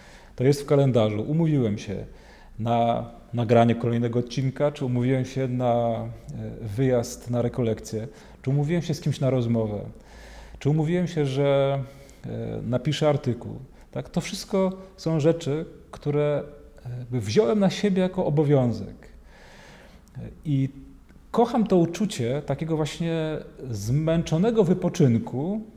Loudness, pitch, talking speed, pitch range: -25 LUFS, 140 Hz, 115 wpm, 120-160 Hz